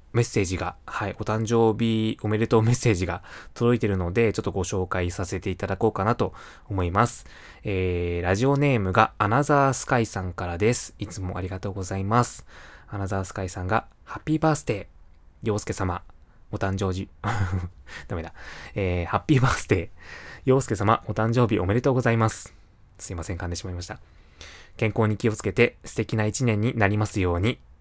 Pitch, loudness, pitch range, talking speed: 105 Hz, -25 LUFS, 95-115 Hz, 385 characters per minute